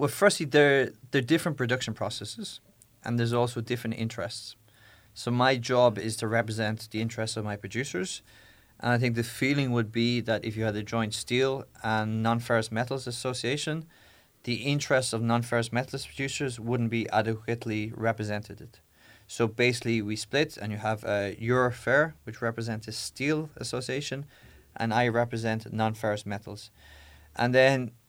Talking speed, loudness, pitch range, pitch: 160 wpm, -28 LUFS, 110-125 Hz, 115 Hz